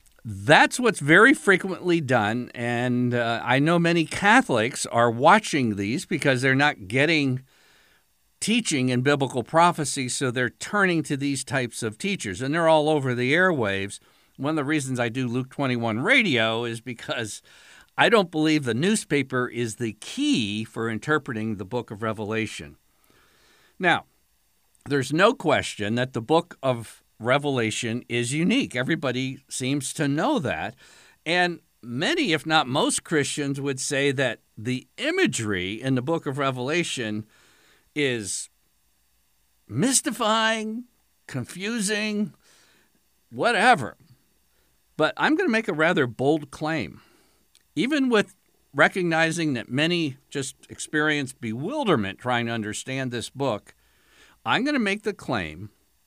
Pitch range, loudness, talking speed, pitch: 120-165 Hz, -23 LUFS, 135 wpm, 135 Hz